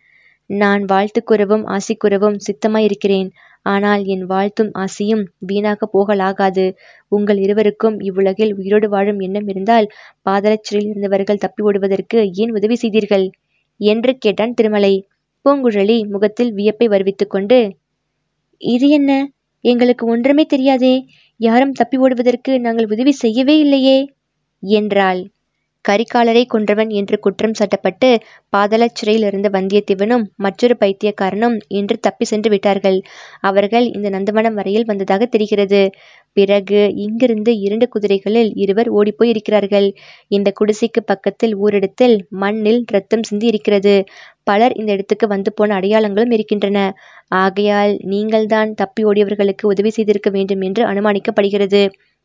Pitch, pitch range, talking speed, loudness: 210 Hz, 200-230 Hz, 110 wpm, -15 LUFS